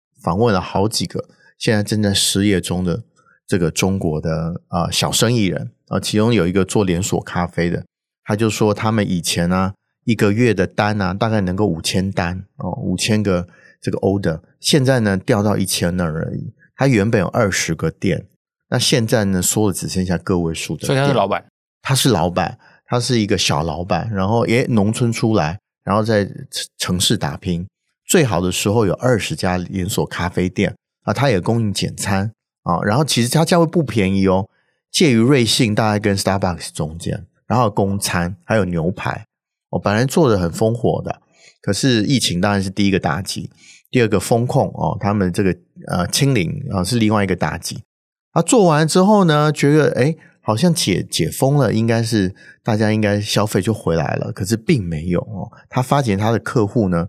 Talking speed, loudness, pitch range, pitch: 290 characters per minute, -18 LUFS, 95-120 Hz, 105 Hz